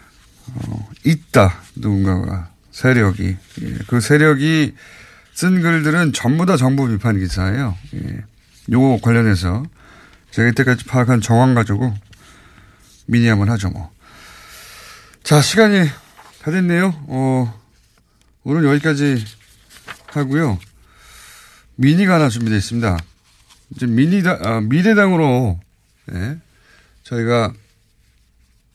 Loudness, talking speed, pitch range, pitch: -16 LUFS, 215 characters per minute, 105-150 Hz, 120 Hz